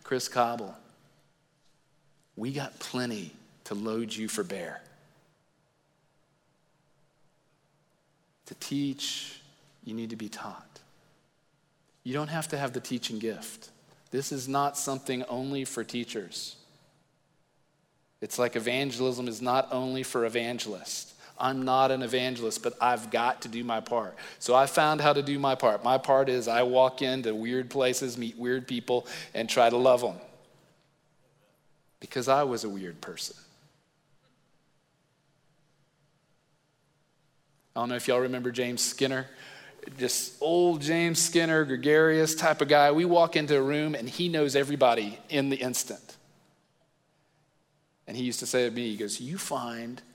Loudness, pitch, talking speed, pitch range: -28 LUFS, 140 Hz, 145 wpm, 125-155 Hz